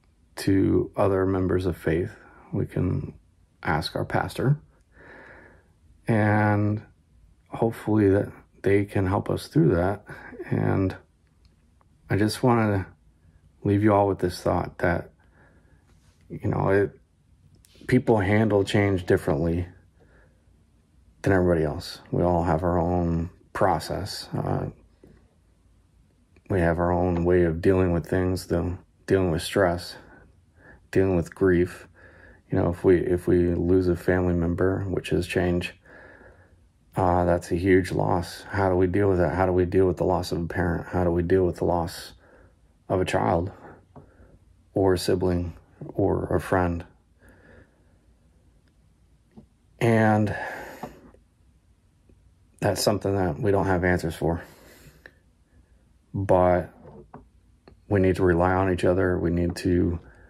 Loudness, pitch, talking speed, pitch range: -24 LUFS, 90 Hz, 130 wpm, 85-95 Hz